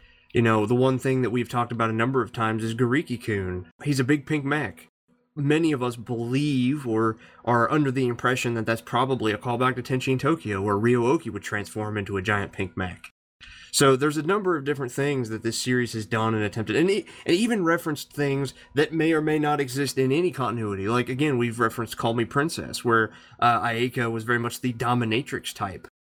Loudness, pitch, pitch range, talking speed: -25 LUFS, 120 Hz, 115-140 Hz, 210 wpm